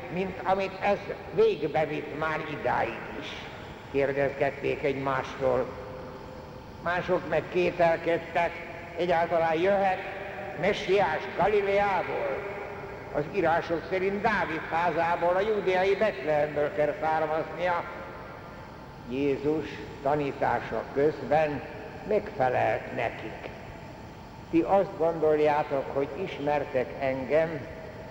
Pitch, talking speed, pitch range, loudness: 165 Hz, 80 wpm, 150-190 Hz, -28 LUFS